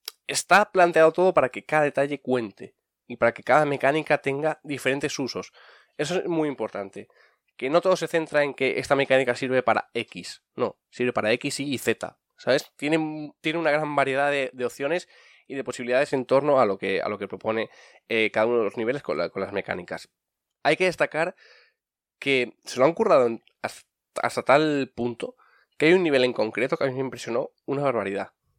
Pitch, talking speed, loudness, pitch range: 140 Hz, 200 wpm, -24 LUFS, 125-150 Hz